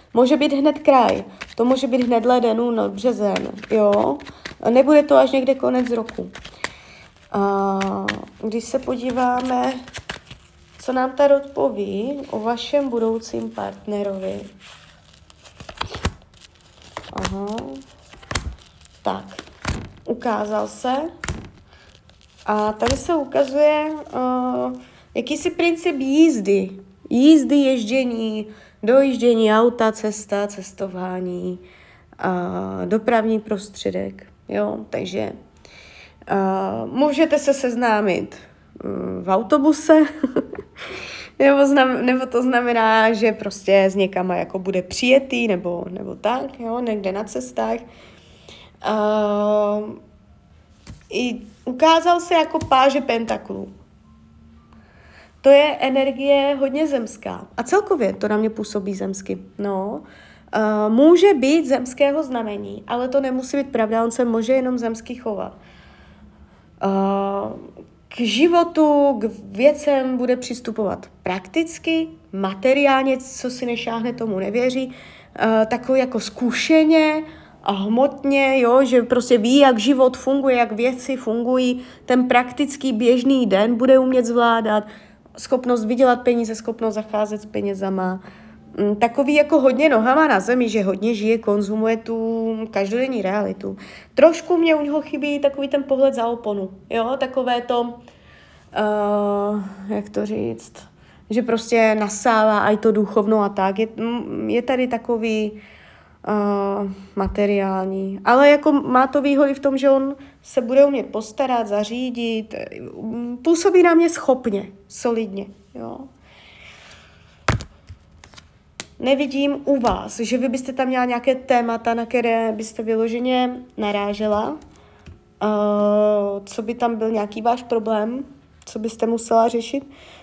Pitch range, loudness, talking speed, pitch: 200-265 Hz, -19 LUFS, 115 wpm, 230 Hz